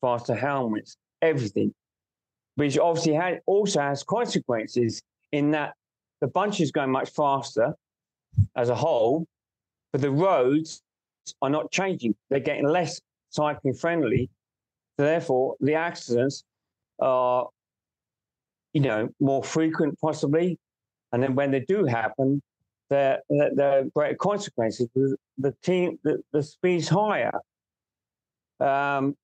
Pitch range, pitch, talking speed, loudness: 125-160 Hz, 140 Hz, 120 wpm, -25 LUFS